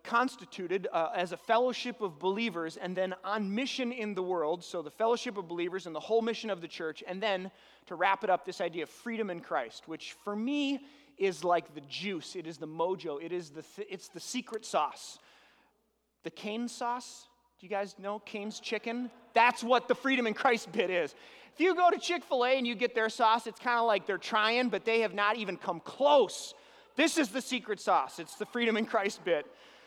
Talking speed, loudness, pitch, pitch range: 220 wpm, -32 LUFS, 215 Hz, 185-240 Hz